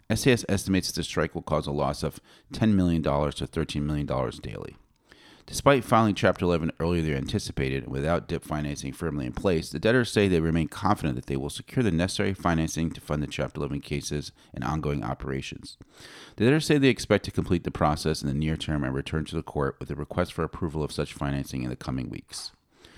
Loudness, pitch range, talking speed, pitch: -27 LUFS, 70-95 Hz, 215 wpm, 80 Hz